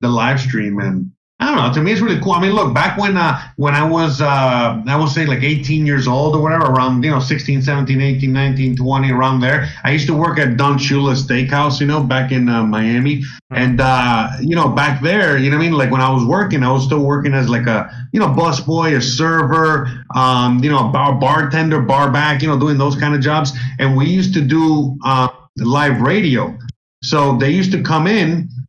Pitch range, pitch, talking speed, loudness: 130-155 Hz, 140 Hz, 235 wpm, -14 LUFS